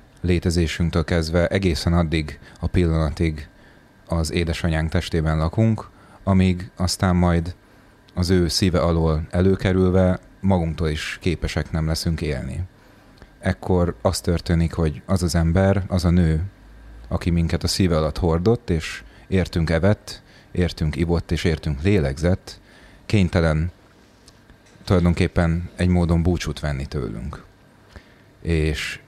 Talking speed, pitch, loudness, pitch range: 115 wpm, 85 Hz, -22 LUFS, 80-95 Hz